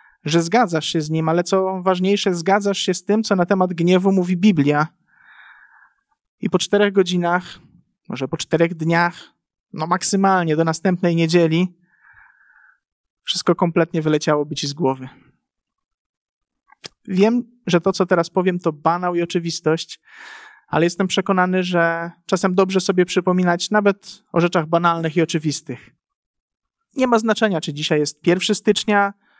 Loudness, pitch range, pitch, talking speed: -19 LUFS, 165-200 Hz, 180 Hz, 140 wpm